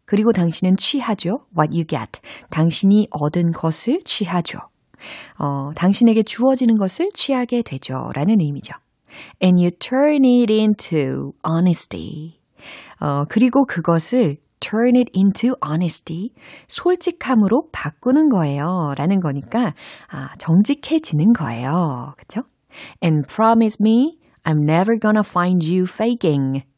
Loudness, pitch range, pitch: -18 LUFS, 160-235 Hz, 190 Hz